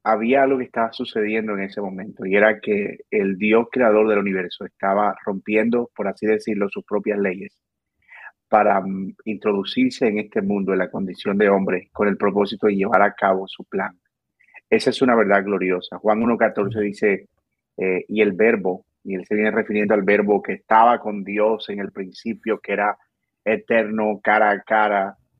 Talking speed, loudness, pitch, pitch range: 175 wpm, -20 LUFS, 105 Hz, 100-110 Hz